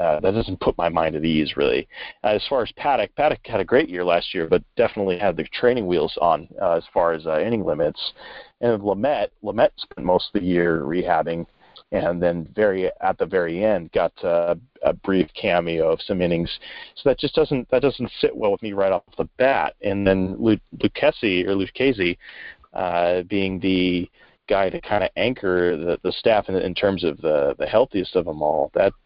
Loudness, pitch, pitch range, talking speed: -22 LUFS, 95 Hz, 85-110 Hz, 210 wpm